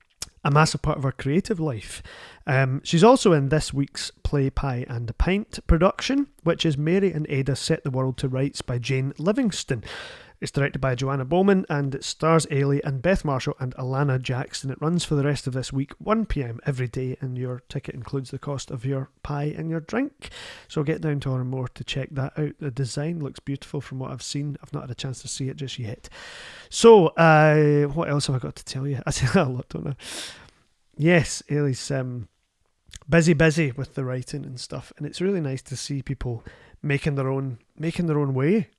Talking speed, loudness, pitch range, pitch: 215 wpm, -24 LUFS, 130-155 Hz, 140 Hz